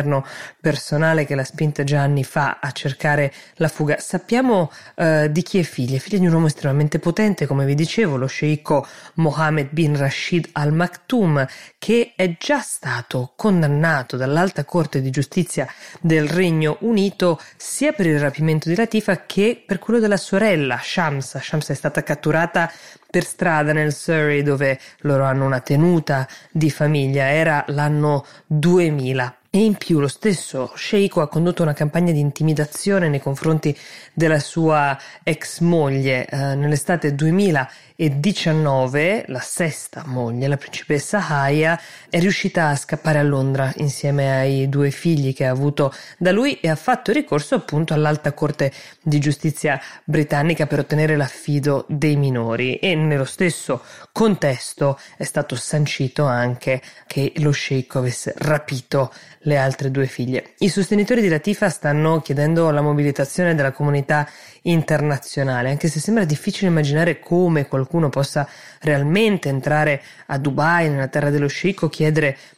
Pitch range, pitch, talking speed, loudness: 140-170 Hz, 150 Hz, 150 wpm, -19 LUFS